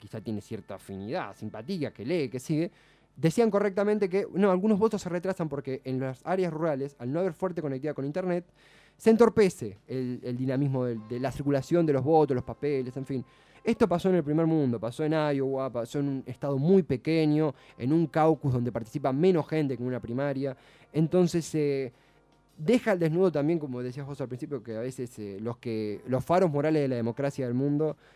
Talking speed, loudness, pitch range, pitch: 205 wpm, -28 LUFS, 125-165 Hz, 140 Hz